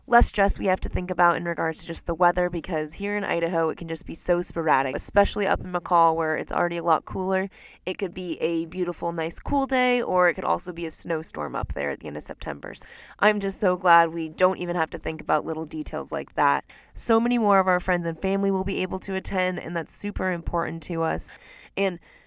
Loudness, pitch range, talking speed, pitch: -25 LUFS, 165-190 Hz, 245 wpm, 175 Hz